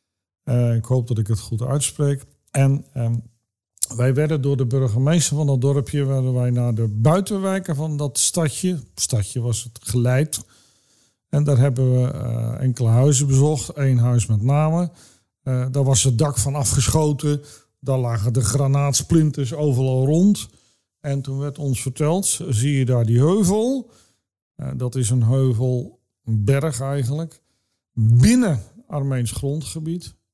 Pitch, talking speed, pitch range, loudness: 135 Hz, 150 wpm, 120-145 Hz, -20 LUFS